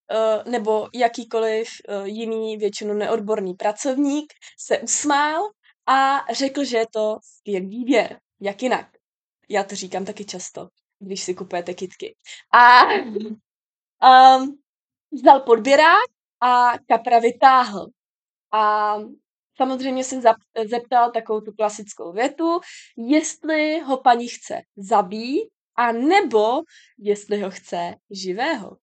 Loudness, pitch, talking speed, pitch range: -19 LUFS, 230 Hz, 110 wpm, 210-270 Hz